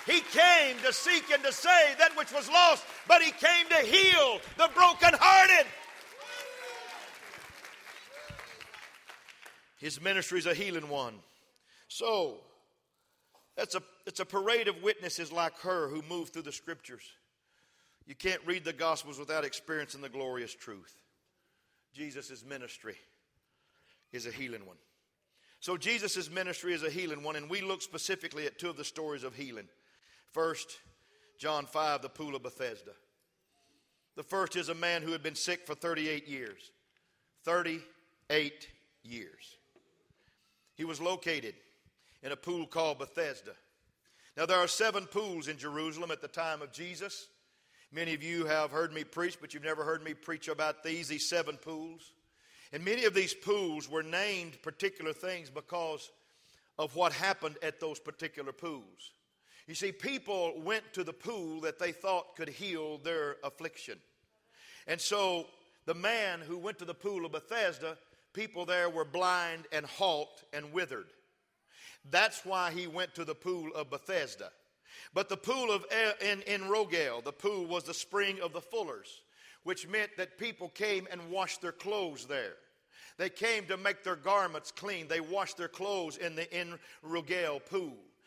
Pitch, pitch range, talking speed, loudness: 175 Hz, 155-200 Hz, 160 wpm, -31 LUFS